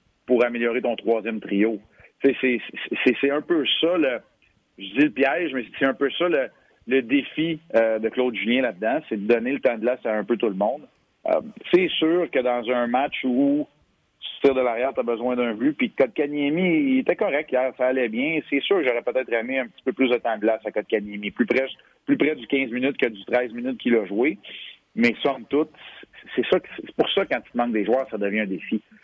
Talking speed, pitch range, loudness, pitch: 240 wpm, 115-155 Hz, -23 LUFS, 125 Hz